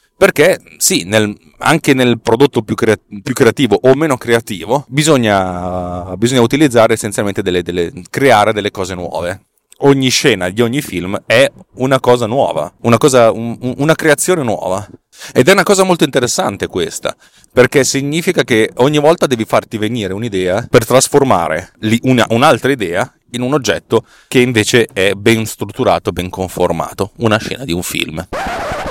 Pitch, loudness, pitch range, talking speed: 115 Hz, -13 LUFS, 105-135 Hz, 155 wpm